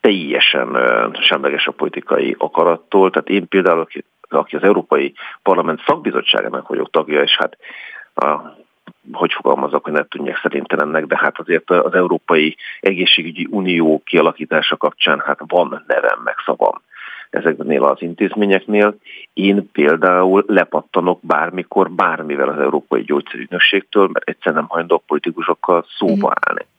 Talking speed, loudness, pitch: 130 wpm, -16 LUFS, 100 Hz